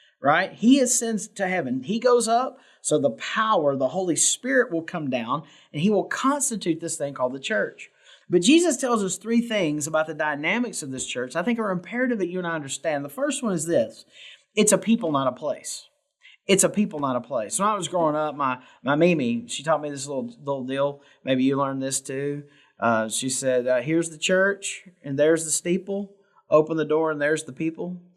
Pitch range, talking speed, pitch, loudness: 145-215 Hz, 215 wpm, 170 Hz, -24 LUFS